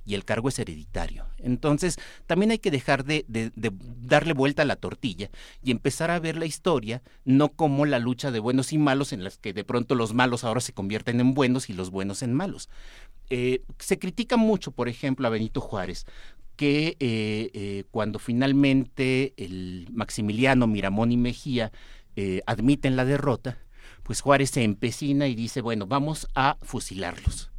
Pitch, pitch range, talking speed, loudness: 125 Hz, 110-140 Hz, 180 wpm, -26 LUFS